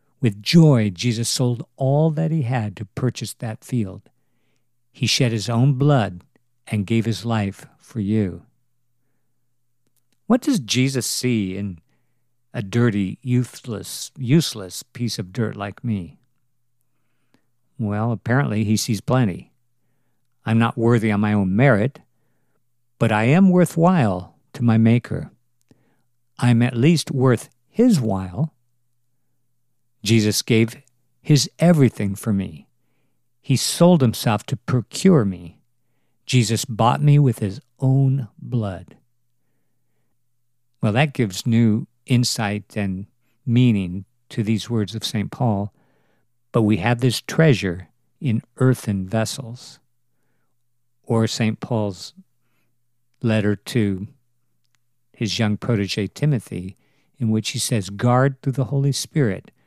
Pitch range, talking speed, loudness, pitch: 110-130 Hz, 120 wpm, -20 LUFS, 120 Hz